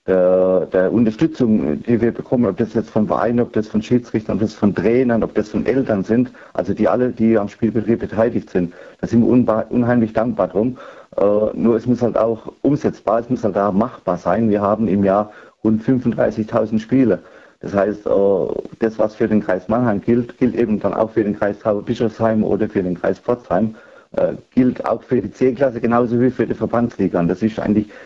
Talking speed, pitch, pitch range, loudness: 200 wpm, 110 Hz, 105-120 Hz, -18 LUFS